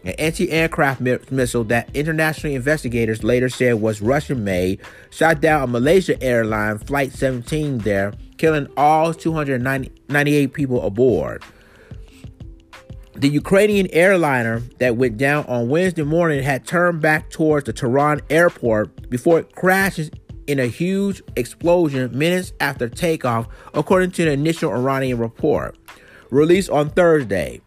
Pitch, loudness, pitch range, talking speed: 140 Hz, -18 LUFS, 125-160 Hz, 125 wpm